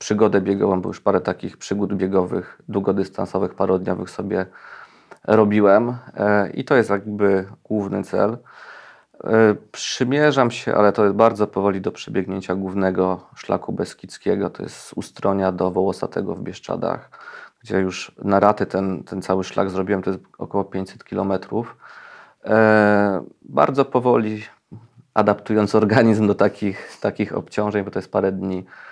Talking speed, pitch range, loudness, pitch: 135 wpm, 95-105 Hz, -20 LUFS, 100 Hz